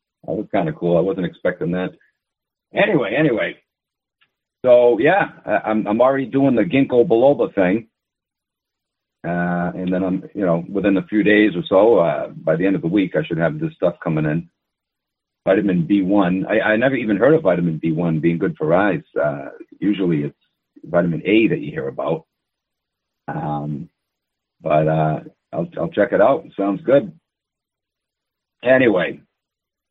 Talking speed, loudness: 165 wpm, -18 LUFS